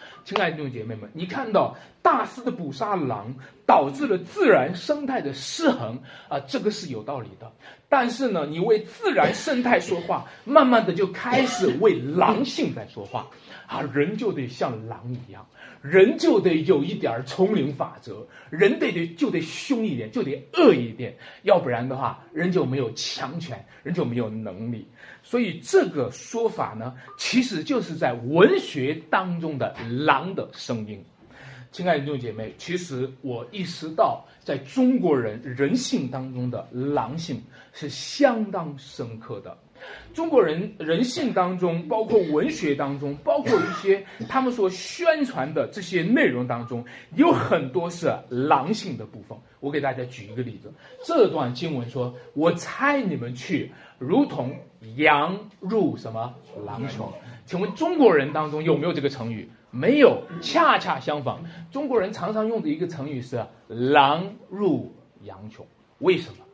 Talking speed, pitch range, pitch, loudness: 235 characters per minute, 125-210 Hz, 155 Hz, -24 LUFS